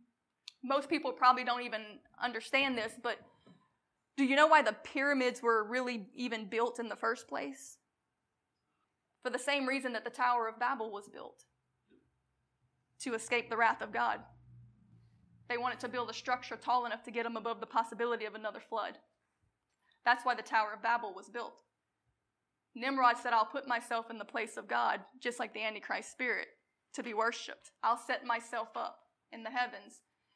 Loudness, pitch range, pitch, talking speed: -34 LUFS, 225-250 Hz, 235 Hz, 175 wpm